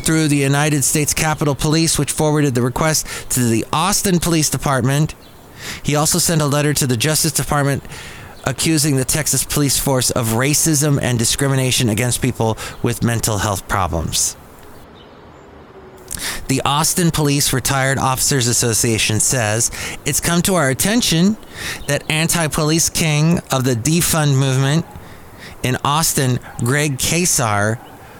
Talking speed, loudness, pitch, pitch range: 130 wpm, -16 LUFS, 145 Hz, 125-155 Hz